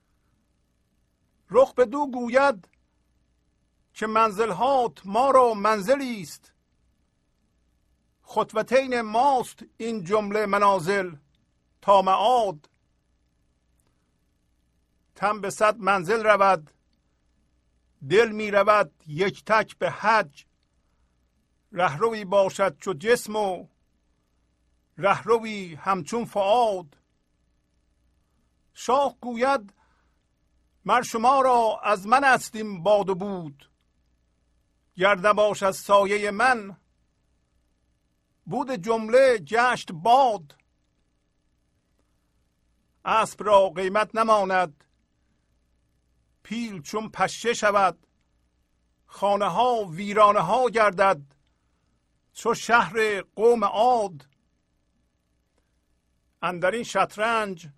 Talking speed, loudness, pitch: 80 wpm, -23 LUFS, 185 Hz